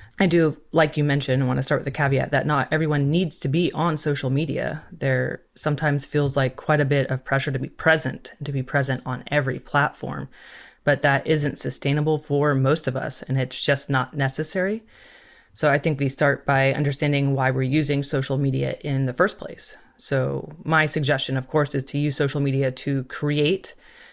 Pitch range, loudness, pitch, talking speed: 135-155 Hz, -23 LUFS, 145 Hz, 200 wpm